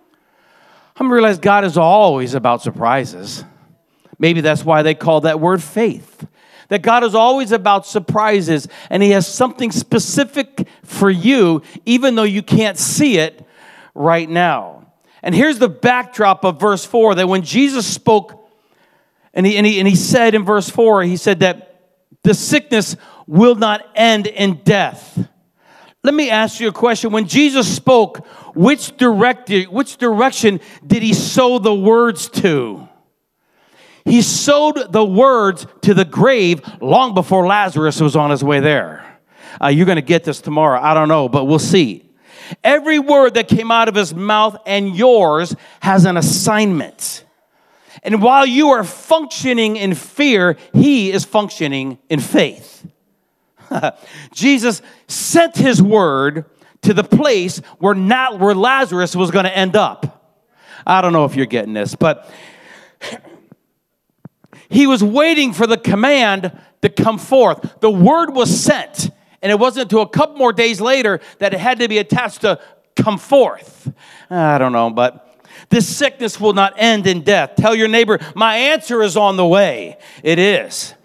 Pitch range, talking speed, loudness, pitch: 180-240 Hz, 160 wpm, -14 LUFS, 210 Hz